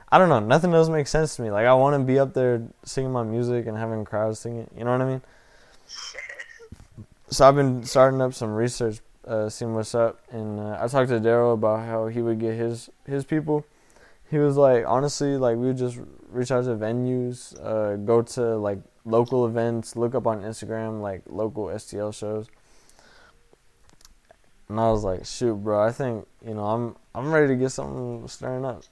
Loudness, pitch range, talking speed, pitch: -24 LUFS, 110-130 Hz, 205 wpm, 115 Hz